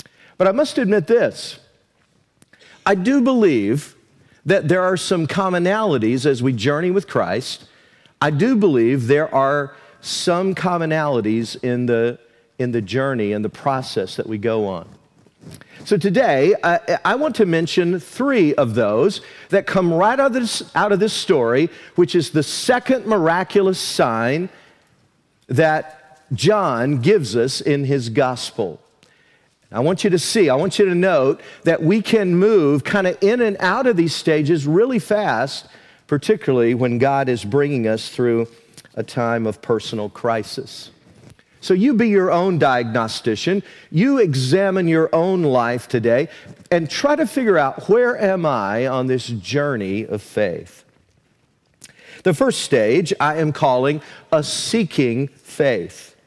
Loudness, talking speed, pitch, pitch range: -18 LUFS, 150 wpm, 155 Hz, 125-190 Hz